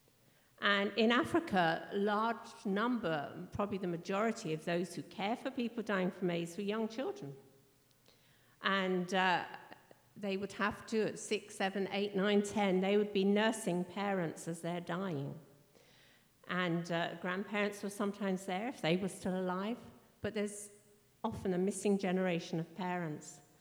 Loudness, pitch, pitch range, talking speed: -36 LUFS, 195 Hz, 175-210 Hz, 155 wpm